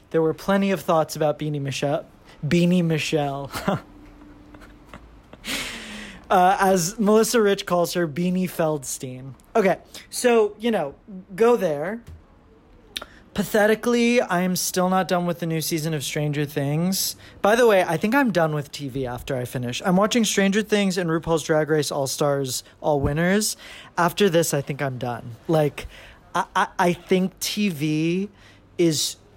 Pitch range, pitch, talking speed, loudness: 145-195 Hz, 170 Hz, 150 wpm, -22 LUFS